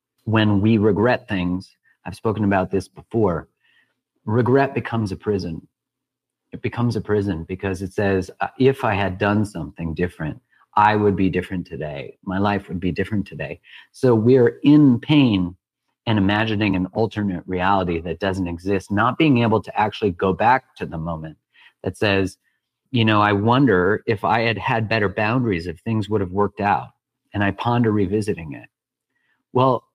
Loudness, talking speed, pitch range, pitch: -20 LUFS, 165 wpm, 95-110 Hz, 100 Hz